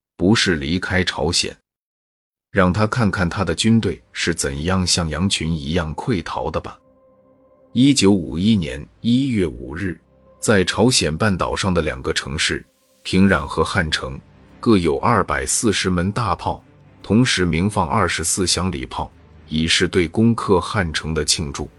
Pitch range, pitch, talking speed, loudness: 85-110 Hz, 95 Hz, 220 characters per minute, -19 LUFS